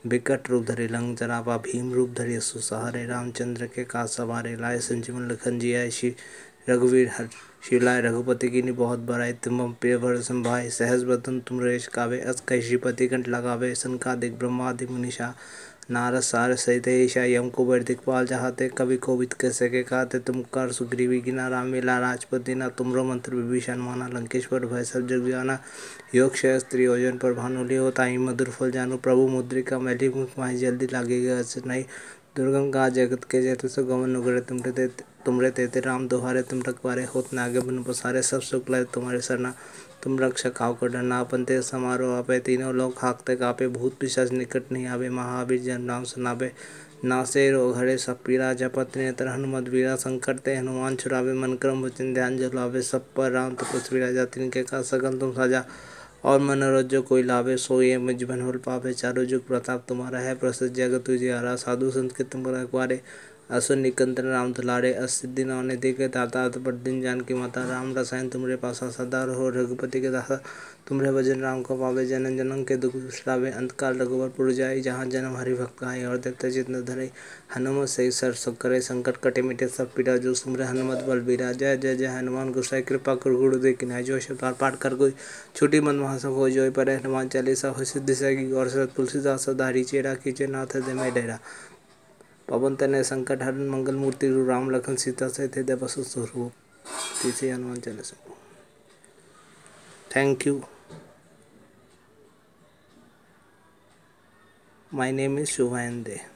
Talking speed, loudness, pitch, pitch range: 155 wpm, -26 LUFS, 130 Hz, 125-130 Hz